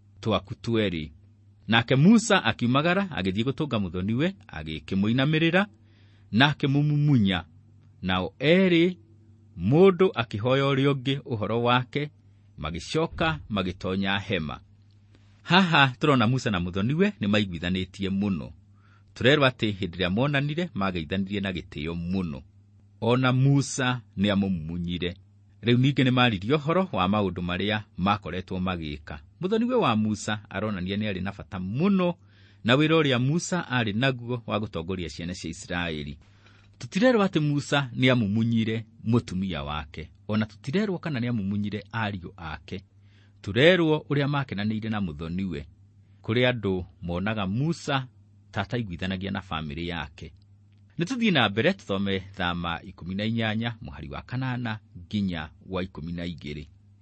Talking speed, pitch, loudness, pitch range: 110 wpm, 105 Hz, -26 LUFS, 95-130 Hz